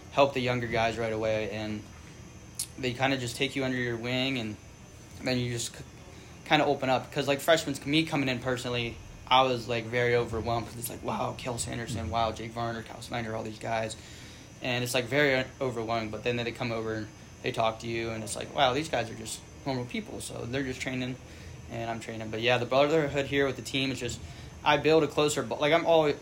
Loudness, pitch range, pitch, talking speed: -29 LUFS, 115-135 Hz, 120 Hz, 235 wpm